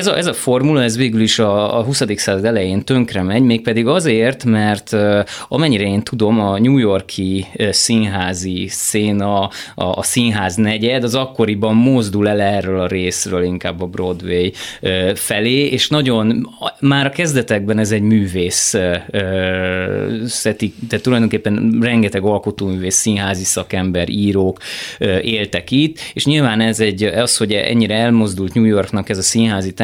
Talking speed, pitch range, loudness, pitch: 140 wpm, 95-115 Hz, -15 LUFS, 105 Hz